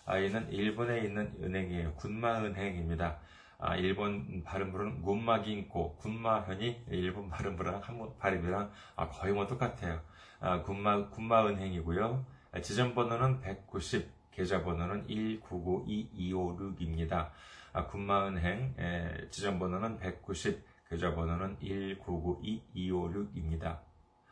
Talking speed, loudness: 245 characters per minute, -36 LUFS